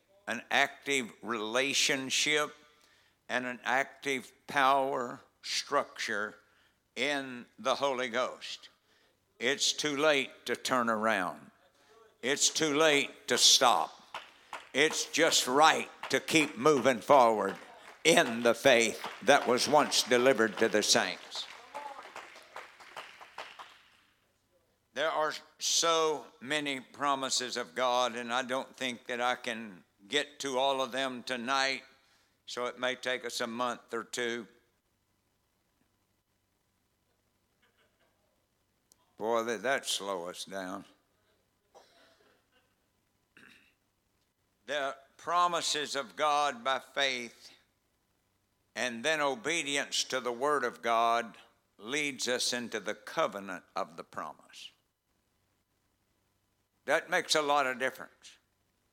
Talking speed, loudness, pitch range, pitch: 105 wpm, -30 LUFS, 115-140 Hz, 125 Hz